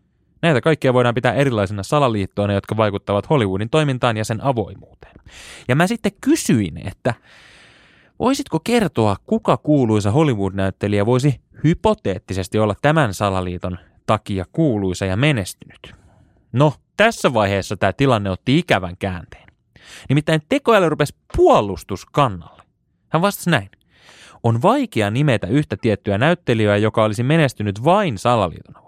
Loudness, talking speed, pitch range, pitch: -18 LUFS, 120 wpm, 100-150 Hz, 115 Hz